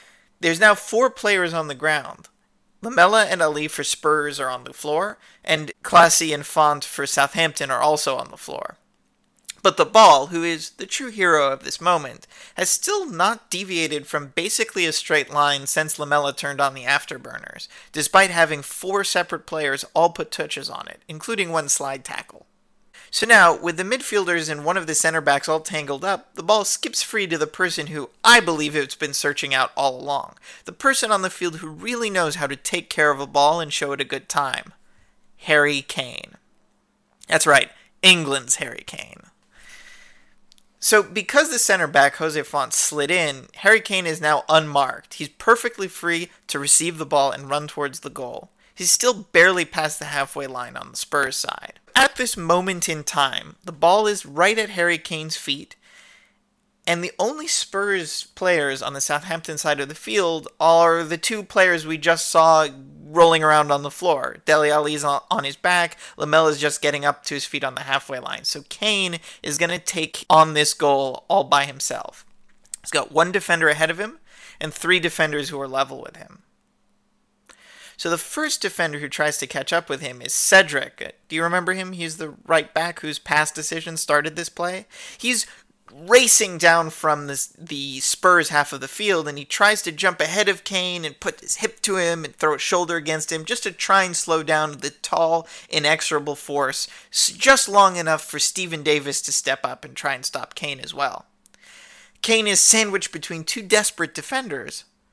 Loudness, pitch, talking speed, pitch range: -20 LUFS, 165 Hz, 190 wpm, 150-190 Hz